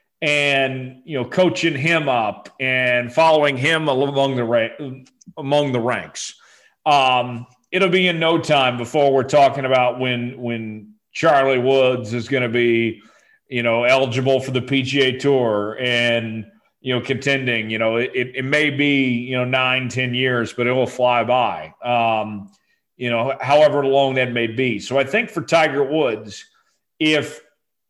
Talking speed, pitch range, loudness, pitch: 160 wpm, 120-145 Hz, -18 LUFS, 130 Hz